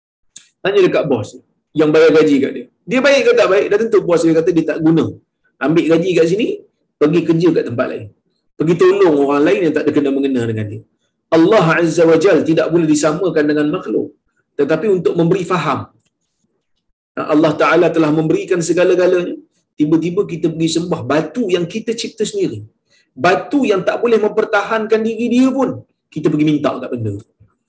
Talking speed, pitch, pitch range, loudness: 175 wpm, 165 Hz, 155-210 Hz, -14 LUFS